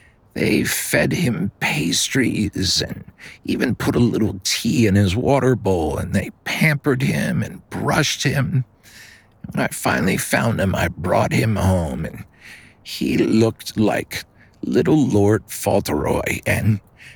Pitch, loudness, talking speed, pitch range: 110 Hz, -19 LUFS, 135 wpm, 100-125 Hz